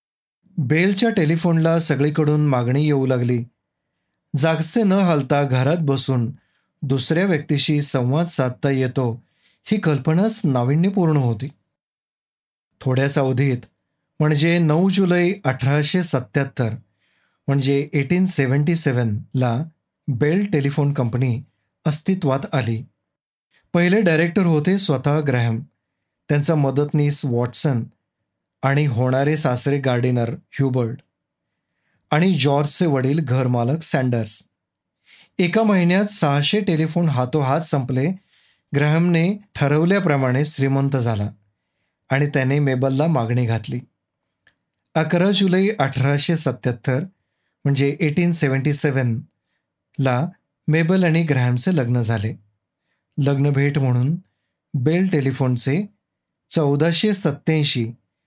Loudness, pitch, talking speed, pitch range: -20 LUFS, 145 Hz, 90 wpm, 130-165 Hz